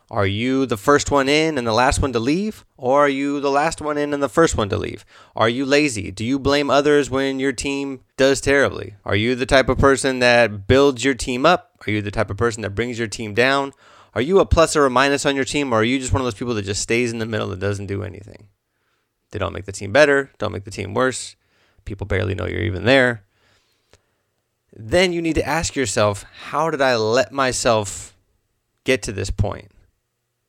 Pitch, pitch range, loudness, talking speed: 120 Hz, 105-140 Hz, -19 LUFS, 235 wpm